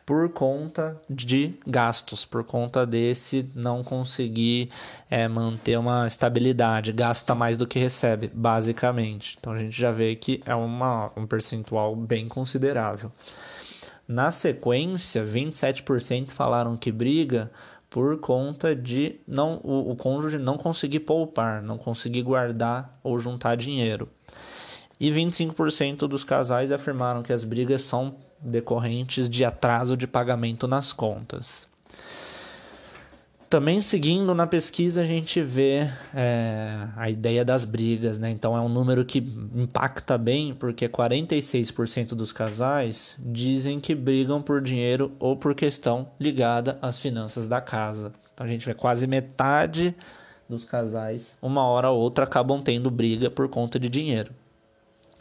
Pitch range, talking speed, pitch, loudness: 115-135 Hz, 135 wpm, 125 Hz, -25 LUFS